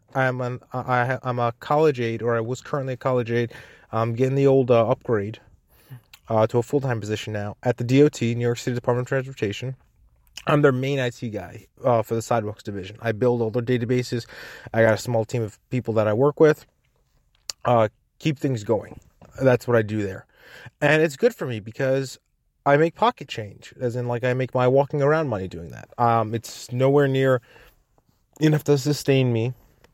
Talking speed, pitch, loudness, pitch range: 200 wpm, 125 Hz, -23 LUFS, 115-135 Hz